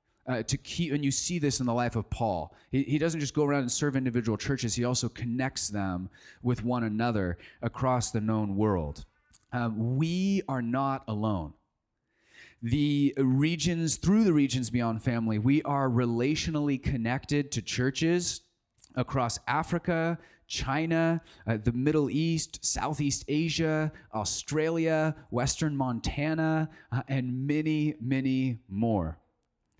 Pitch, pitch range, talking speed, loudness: 130 Hz, 115-150 Hz, 135 wpm, -29 LUFS